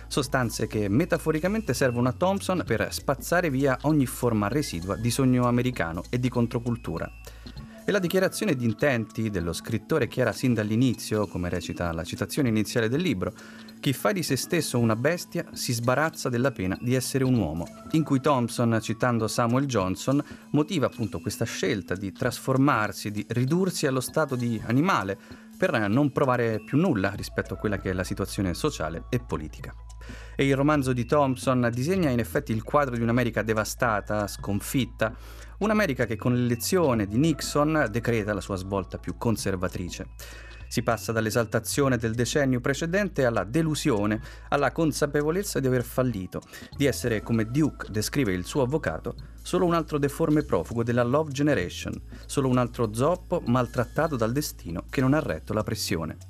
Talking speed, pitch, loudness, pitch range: 160 wpm, 120 Hz, -26 LUFS, 105-145 Hz